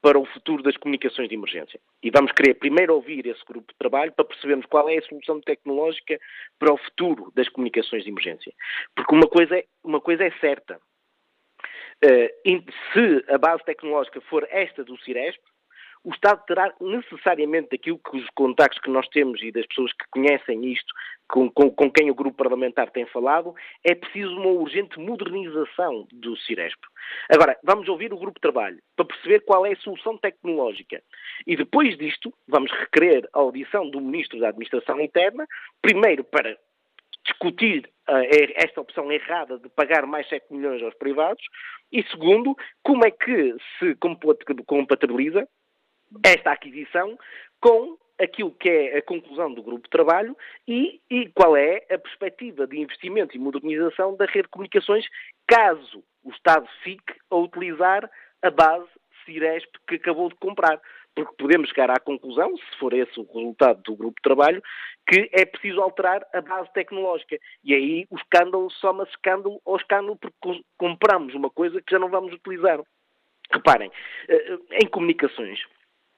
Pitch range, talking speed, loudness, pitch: 145-235 Hz, 165 wpm, -22 LUFS, 175 Hz